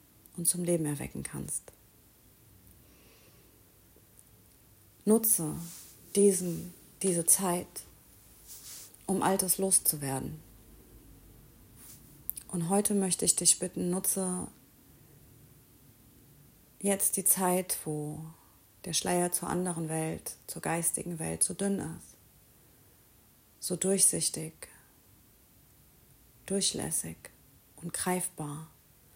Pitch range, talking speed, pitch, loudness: 130-185 Hz, 80 wpm, 165 Hz, -29 LUFS